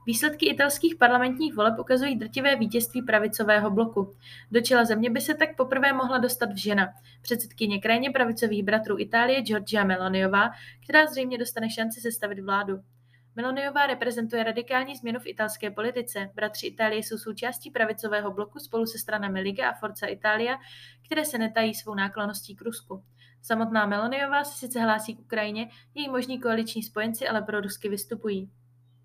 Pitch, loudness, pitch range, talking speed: 225 Hz, -26 LUFS, 210-250 Hz, 155 wpm